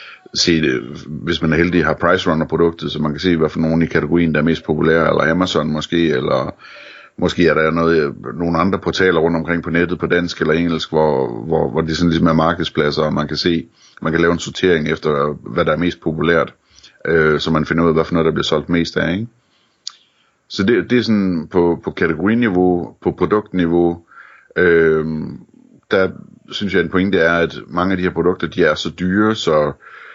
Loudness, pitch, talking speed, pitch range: -16 LUFS, 85 Hz, 215 wpm, 80-85 Hz